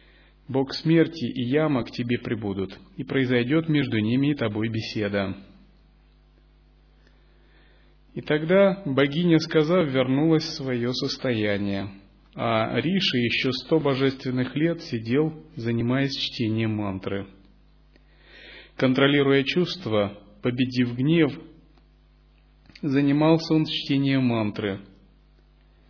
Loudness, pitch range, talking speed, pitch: -24 LUFS, 110-150 Hz, 95 wpm, 130 Hz